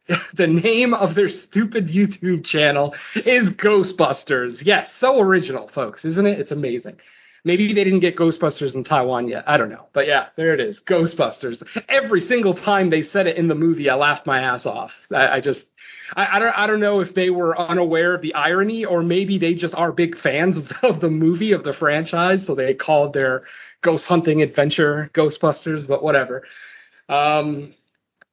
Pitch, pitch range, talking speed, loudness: 170 Hz, 150-190 Hz, 185 wpm, -19 LUFS